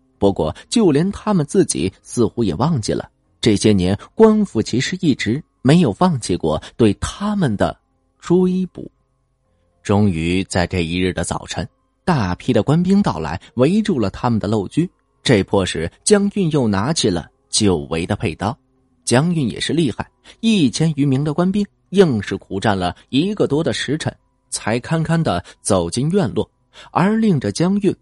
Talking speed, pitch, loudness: 235 characters per minute, 125 Hz, -18 LUFS